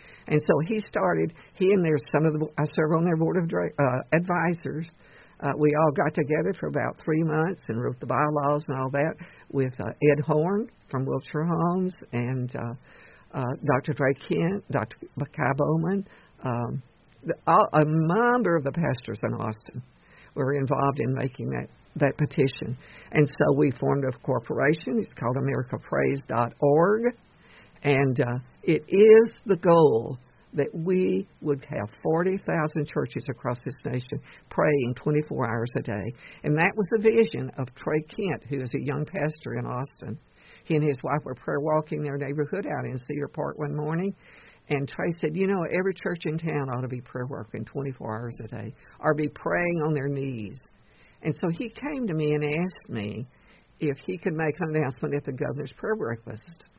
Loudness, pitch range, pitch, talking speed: -26 LUFS, 135-165 Hz, 150 Hz, 180 wpm